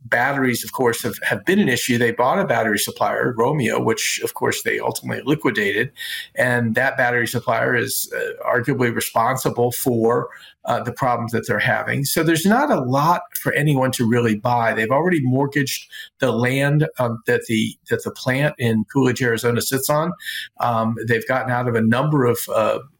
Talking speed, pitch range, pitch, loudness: 185 wpm, 120-150 Hz, 125 Hz, -19 LUFS